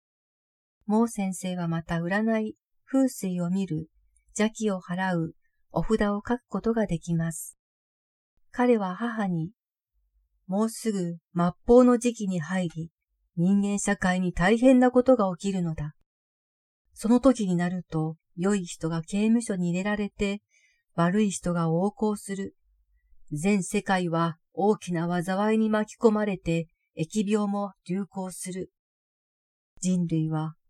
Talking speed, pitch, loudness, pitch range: 230 characters per minute, 190 Hz, -26 LUFS, 170-215 Hz